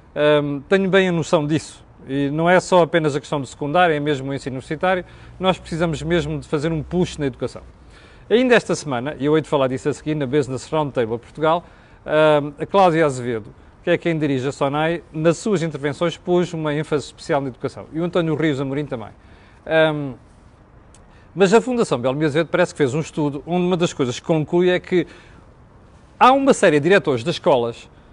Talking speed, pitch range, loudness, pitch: 200 wpm, 140-175 Hz, -19 LUFS, 155 Hz